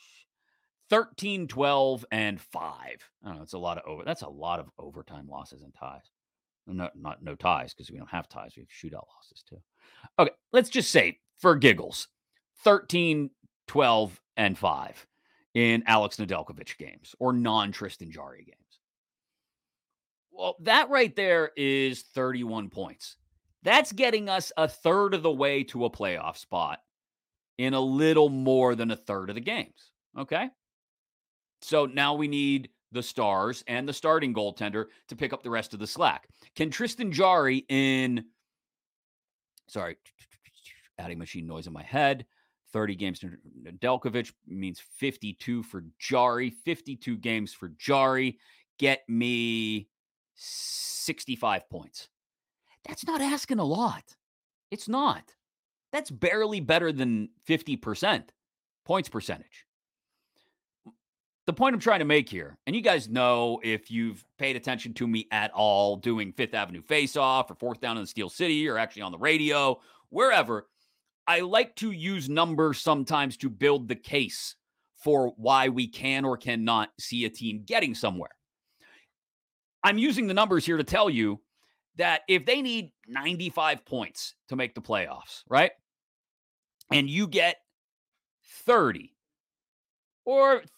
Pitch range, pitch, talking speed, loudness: 110-160 Hz, 130 Hz, 150 wpm, -27 LUFS